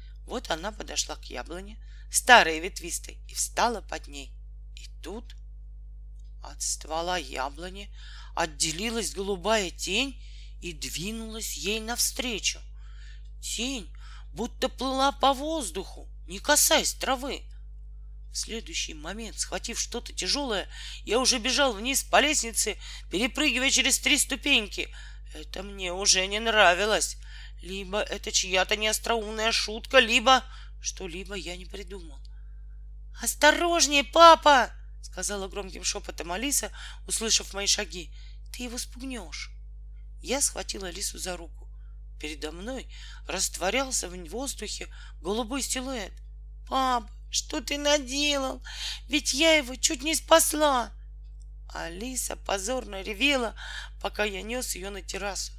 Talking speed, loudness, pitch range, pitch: 115 wpm, -26 LUFS, 160-255 Hz, 205 Hz